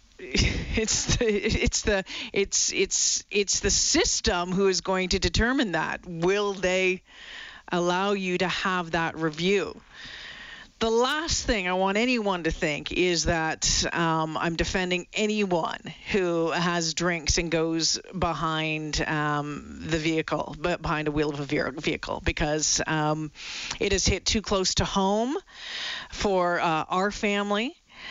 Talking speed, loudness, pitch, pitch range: 140 wpm, -25 LUFS, 180 Hz, 160-205 Hz